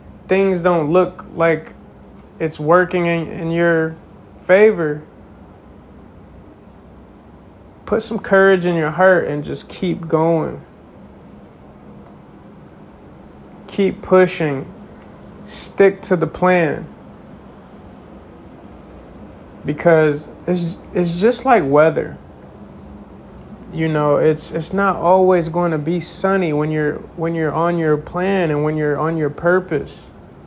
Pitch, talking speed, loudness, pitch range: 165 Hz, 110 wpm, -17 LUFS, 150-185 Hz